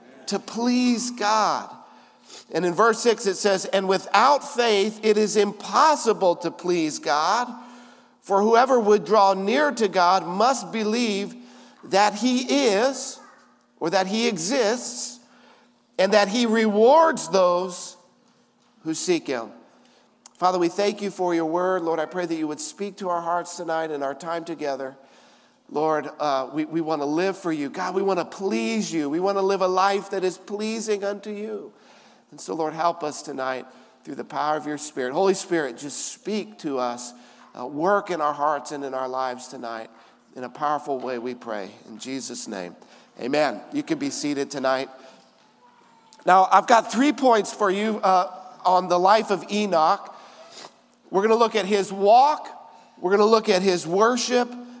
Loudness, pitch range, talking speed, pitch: -22 LUFS, 155-220 Hz, 175 wpm, 190 Hz